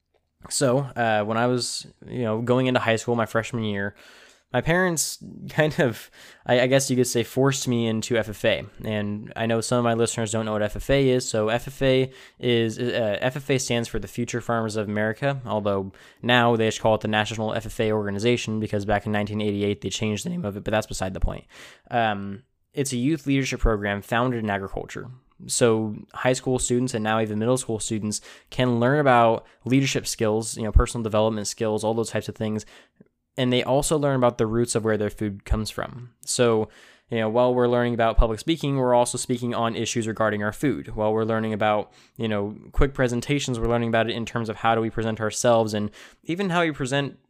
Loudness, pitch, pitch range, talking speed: -24 LUFS, 115 Hz, 110-125 Hz, 210 wpm